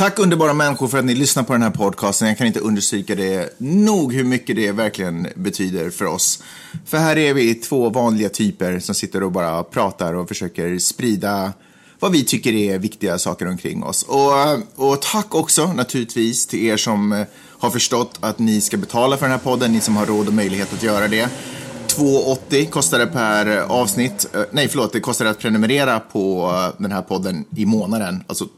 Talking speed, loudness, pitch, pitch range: 195 wpm, -18 LUFS, 110 Hz, 100-130 Hz